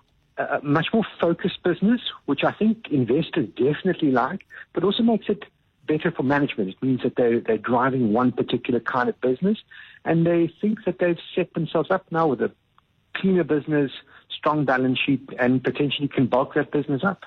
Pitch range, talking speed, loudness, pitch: 135-180 Hz, 180 wpm, -23 LUFS, 155 Hz